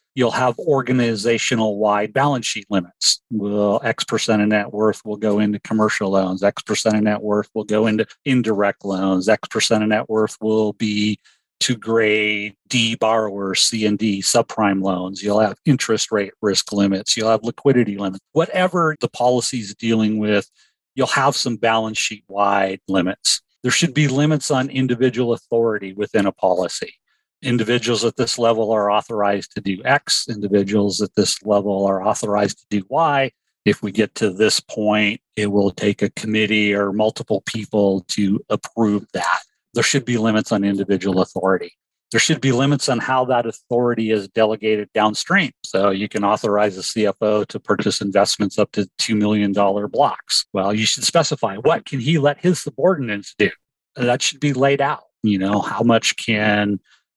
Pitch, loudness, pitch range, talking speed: 110 Hz, -19 LUFS, 100-120 Hz, 175 wpm